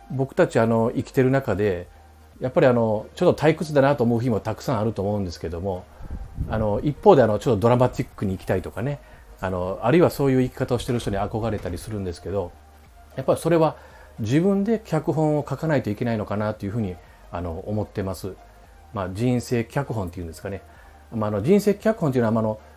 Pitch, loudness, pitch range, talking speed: 110 Hz, -23 LUFS, 95-135 Hz, 450 characters per minute